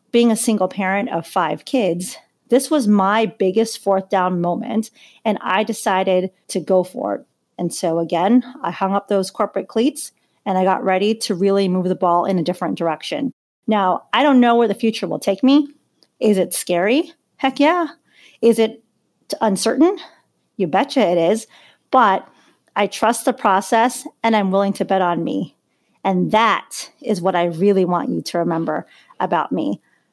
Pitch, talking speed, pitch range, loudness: 205 Hz, 175 wpm, 185-235 Hz, -18 LUFS